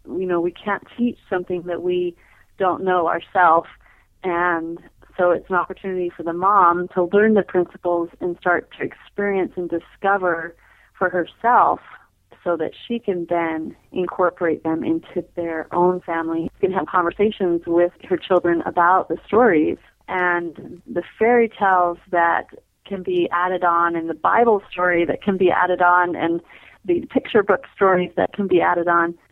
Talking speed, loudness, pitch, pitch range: 165 wpm, -20 LUFS, 180 Hz, 170-190 Hz